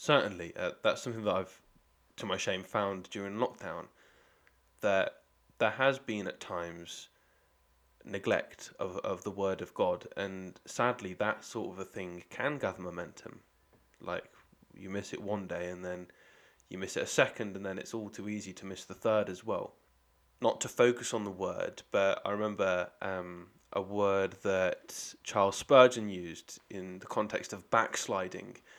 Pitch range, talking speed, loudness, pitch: 90-105 Hz, 170 wpm, -34 LUFS, 95 Hz